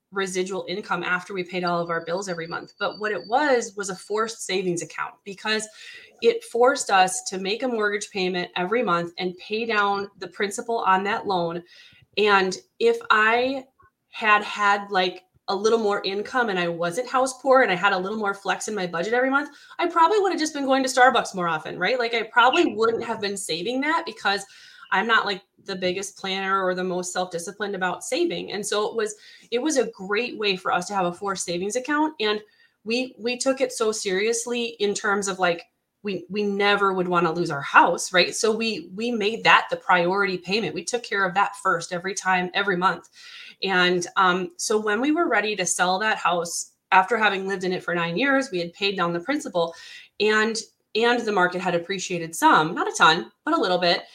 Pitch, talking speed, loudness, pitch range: 200 Hz, 215 wpm, -23 LUFS, 185-240 Hz